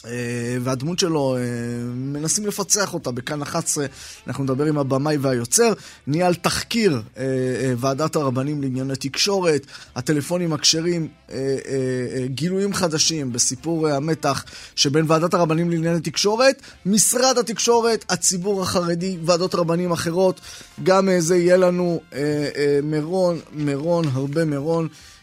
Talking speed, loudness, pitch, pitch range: 105 wpm, -21 LUFS, 160 Hz, 135-180 Hz